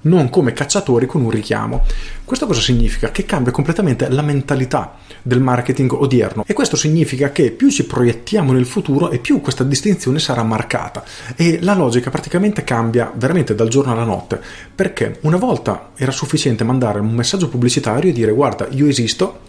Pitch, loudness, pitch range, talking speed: 130 Hz, -16 LUFS, 120-155 Hz, 170 wpm